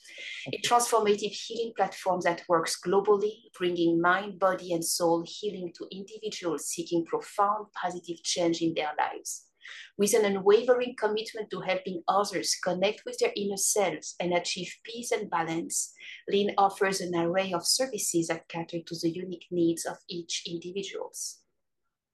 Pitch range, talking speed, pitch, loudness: 170-210 Hz, 145 wpm, 190 Hz, -29 LUFS